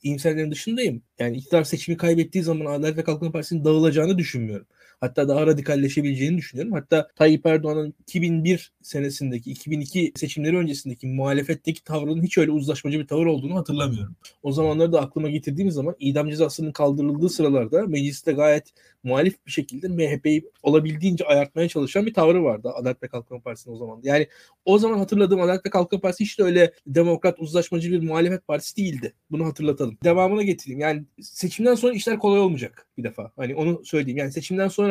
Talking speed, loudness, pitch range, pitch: 165 wpm, -22 LUFS, 145-175 Hz, 155 Hz